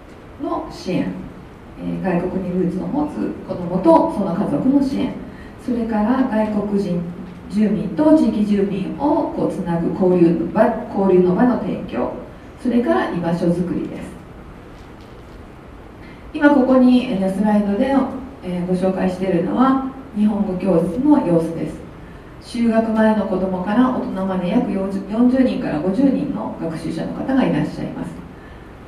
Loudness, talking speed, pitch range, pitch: -19 LUFS, 265 characters per minute, 185-255 Hz, 210 Hz